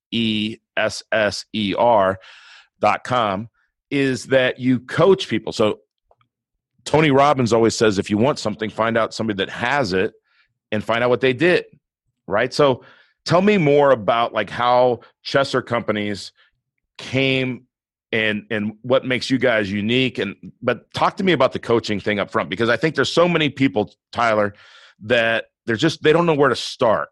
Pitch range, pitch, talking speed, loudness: 110-135 Hz, 120 Hz, 175 wpm, -19 LUFS